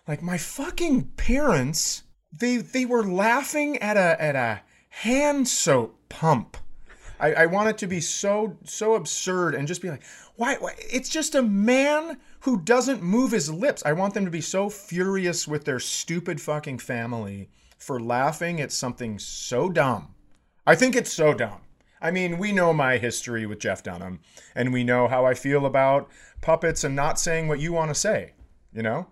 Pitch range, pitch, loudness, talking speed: 140-220 Hz, 170 Hz, -24 LUFS, 185 wpm